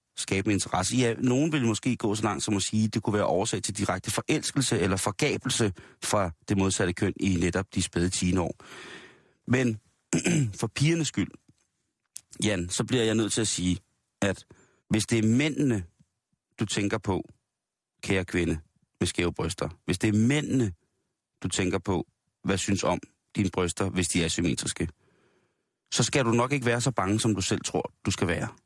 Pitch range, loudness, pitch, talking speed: 95-120 Hz, -27 LUFS, 105 Hz, 185 wpm